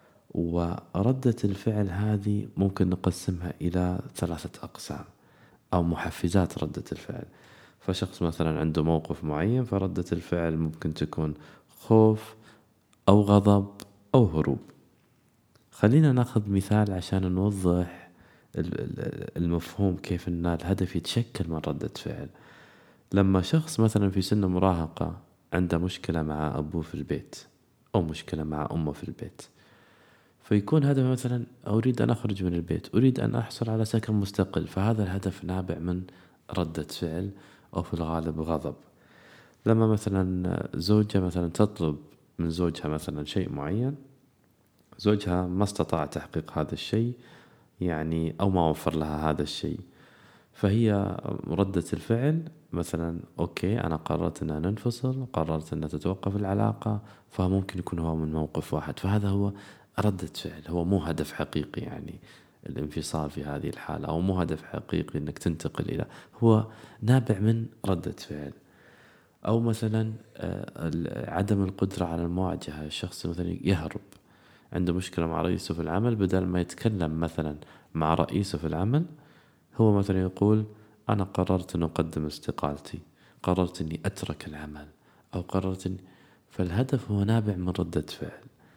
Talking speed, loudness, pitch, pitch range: 130 wpm, -28 LUFS, 95 Hz, 85-105 Hz